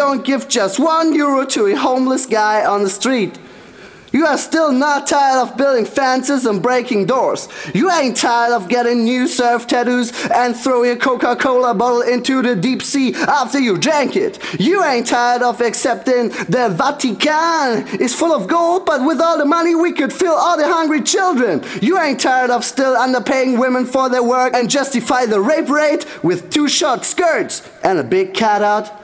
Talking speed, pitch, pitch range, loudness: 190 wpm, 265 Hz, 245-300 Hz, -15 LUFS